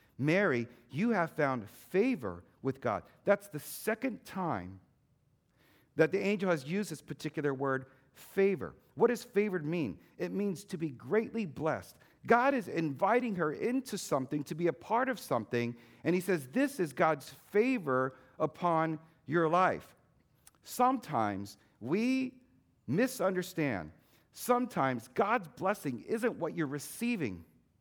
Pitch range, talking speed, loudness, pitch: 135-205 Hz, 135 wpm, -33 LUFS, 160 Hz